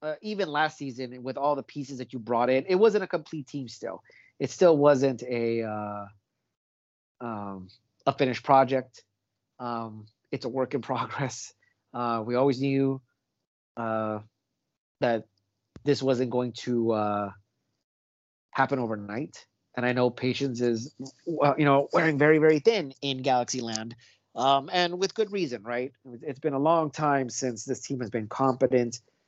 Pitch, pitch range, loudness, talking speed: 125 Hz, 115-140 Hz, -27 LUFS, 160 wpm